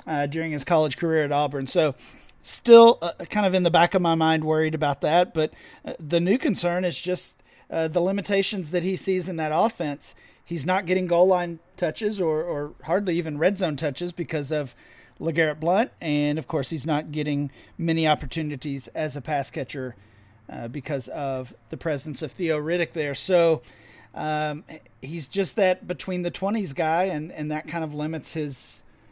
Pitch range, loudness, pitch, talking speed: 145-175 Hz, -24 LUFS, 160 Hz, 190 wpm